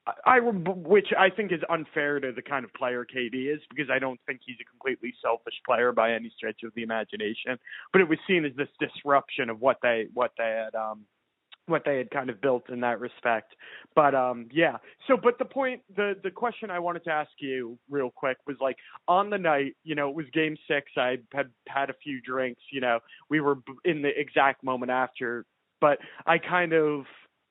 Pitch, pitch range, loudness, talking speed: 140 Hz, 125-165 Hz, -27 LUFS, 215 wpm